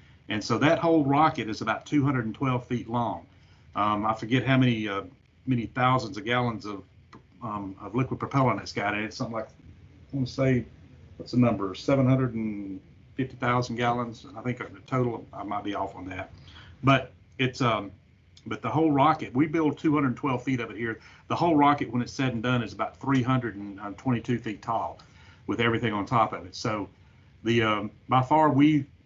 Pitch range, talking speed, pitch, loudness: 105-130 Hz, 180 wpm, 120 Hz, -27 LUFS